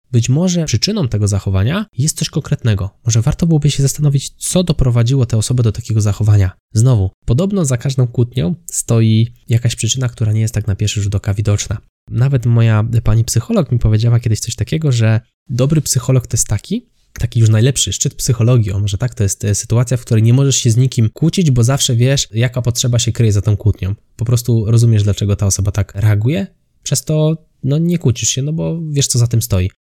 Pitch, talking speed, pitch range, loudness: 120 Hz, 205 wpm, 110-135 Hz, -15 LUFS